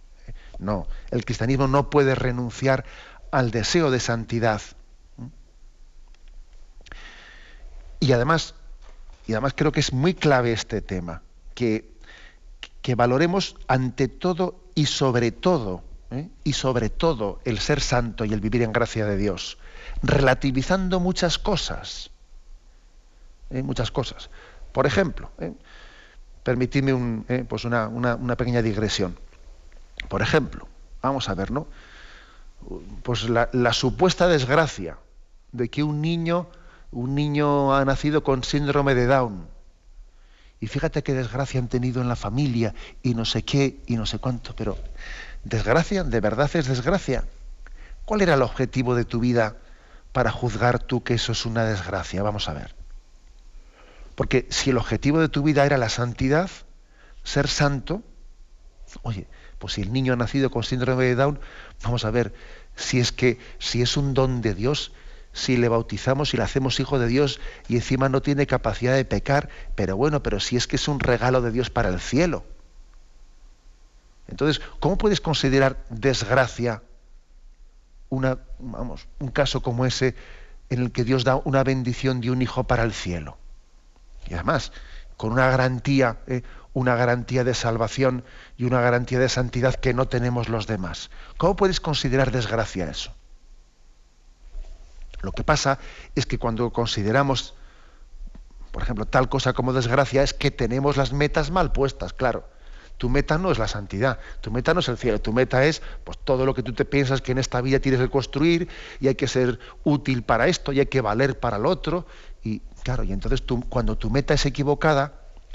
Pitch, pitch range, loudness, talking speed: 125 Hz, 115-140 Hz, -23 LUFS, 165 wpm